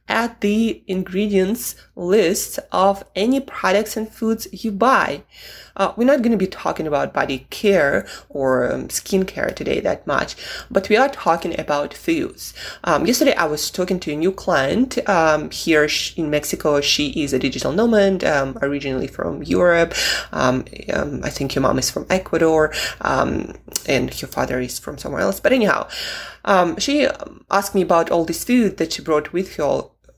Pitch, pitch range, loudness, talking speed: 190 Hz, 155-225 Hz, -19 LUFS, 175 wpm